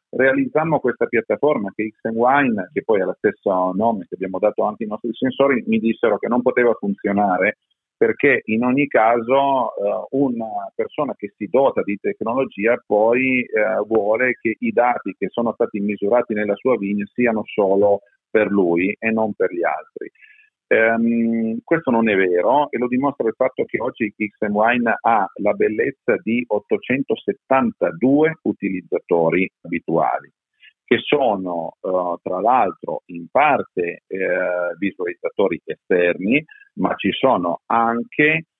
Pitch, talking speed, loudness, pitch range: 115 Hz, 145 wpm, -19 LUFS, 105-135 Hz